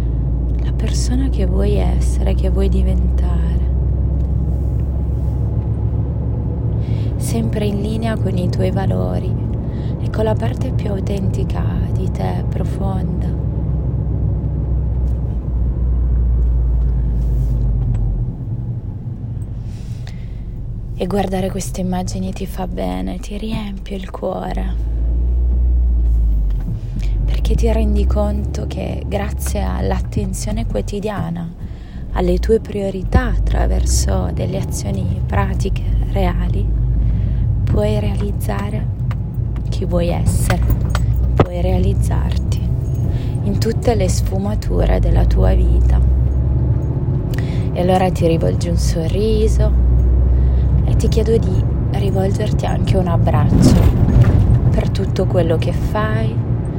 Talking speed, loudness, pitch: 90 wpm, -18 LUFS, 95 Hz